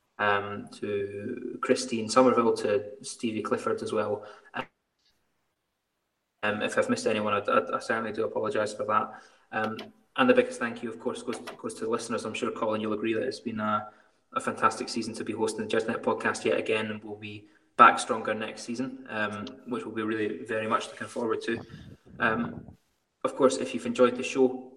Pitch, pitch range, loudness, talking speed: 110 Hz, 105-130 Hz, -28 LUFS, 195 wpm